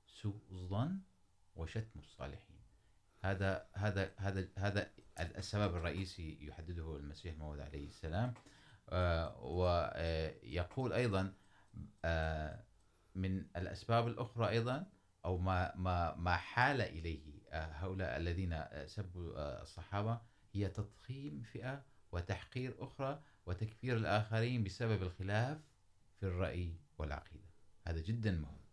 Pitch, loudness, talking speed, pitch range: 95 Hz, -41 LUFS, 95 wpm, 85-110 Hz